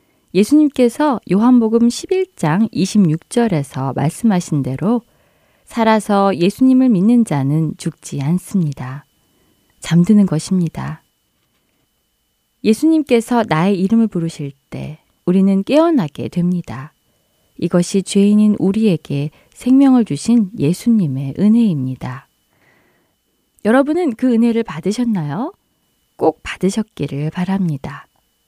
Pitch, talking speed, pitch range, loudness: 195 Hz, 240 characters per minute, 155-230 Hz, -16 LUFS